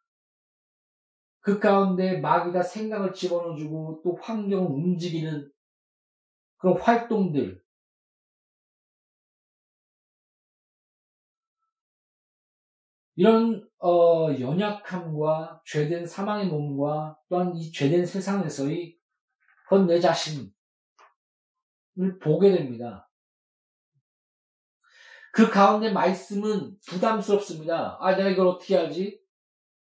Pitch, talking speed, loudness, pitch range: 180 Hz, 175 characters per minute, -25 LUFS, 165-205 Hz